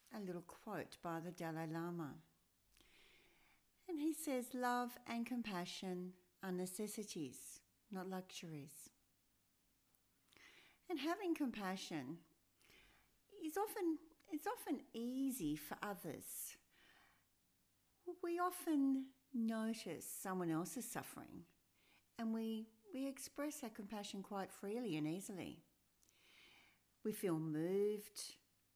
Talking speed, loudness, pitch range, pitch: 95 wpm, -46 LUFS, 170-270 Hz, 210 Hz